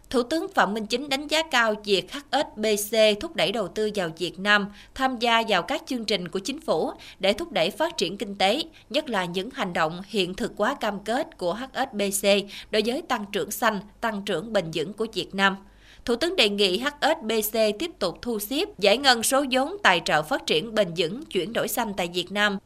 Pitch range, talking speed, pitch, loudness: 200-255 Hz, 215 wpm, 220 Hz, -25 LUFS